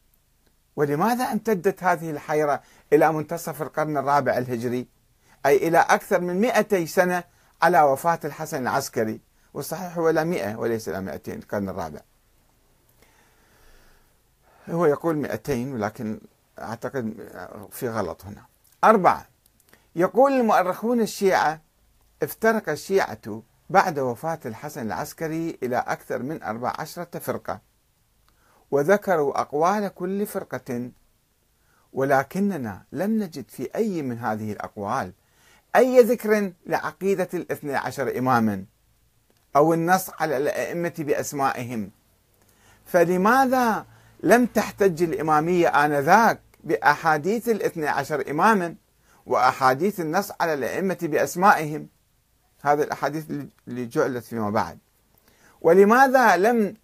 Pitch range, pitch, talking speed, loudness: 120-185 Hz, 155 Hz, 100 wpm, -23 LUFS